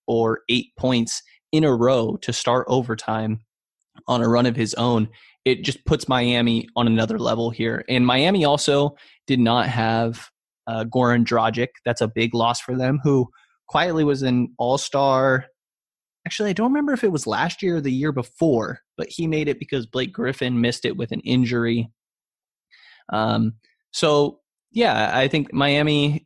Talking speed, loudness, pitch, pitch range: 170 wpm, -21 LUFS, 125 Hz, 115-145 Hz